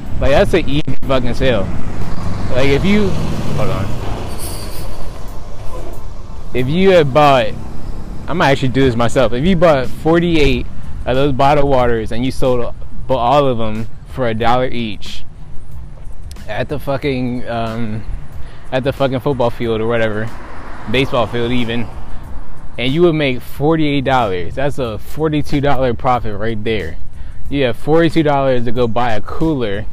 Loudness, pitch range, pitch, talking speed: -16 LUFS, 110-140 Hz, 125 Hz, 145 wpm